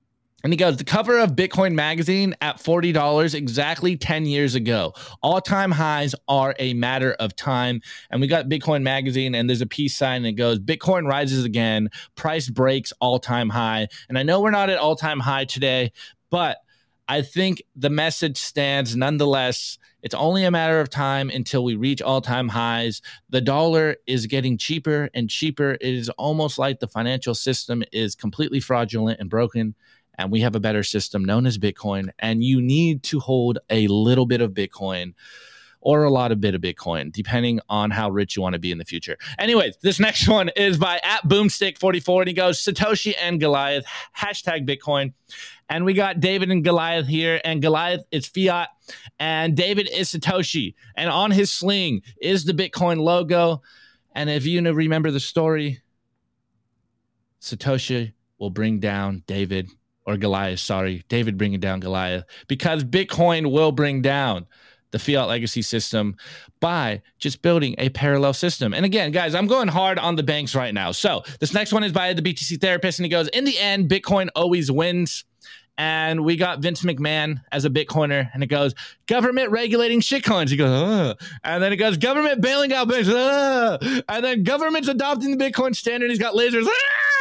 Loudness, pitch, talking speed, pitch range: -21 LUFS, 145 Hz, 185 wpm, 120-180 Hz